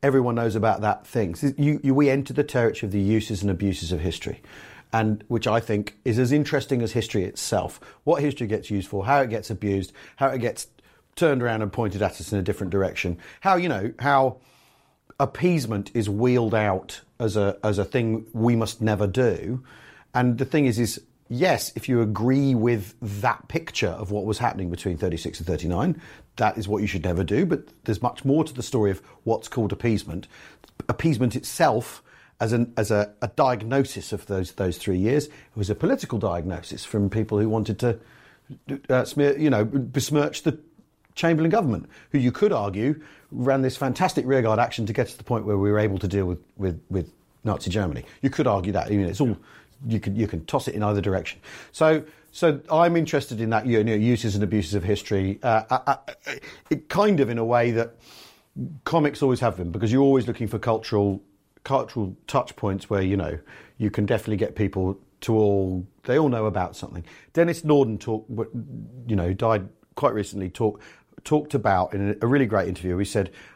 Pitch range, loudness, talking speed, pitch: 100-135 Hz, -24 LUFS, 205 wpm, 110 Hz